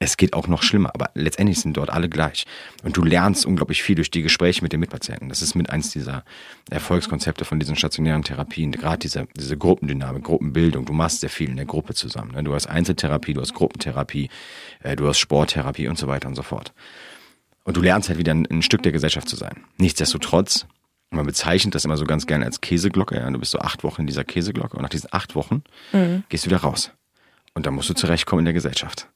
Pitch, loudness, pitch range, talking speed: 80 Hz, -22 LUFS, 75-85 Hz, 220 wpm